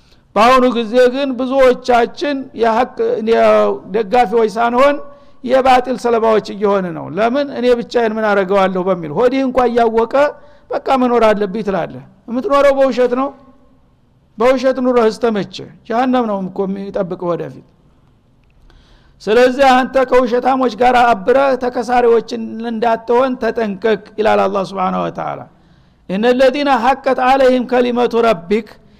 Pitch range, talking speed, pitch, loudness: 220-255 Hz, 110 wpm, 240 Hz, -14 LUFS